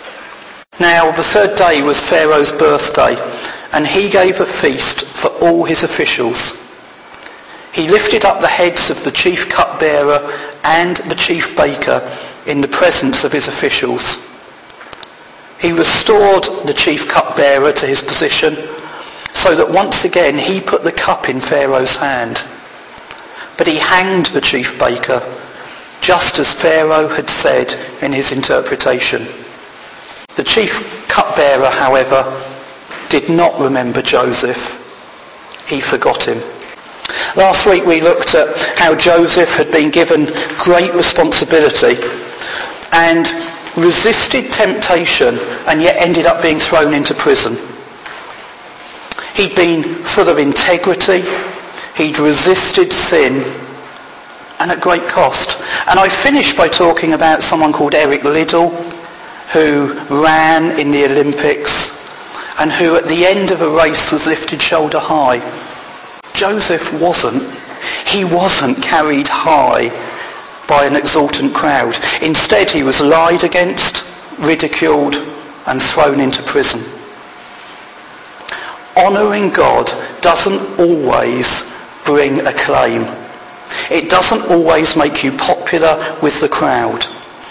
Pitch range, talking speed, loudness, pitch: 150-180 Hz, 120 wpm, -11 LUFS, 165 Hz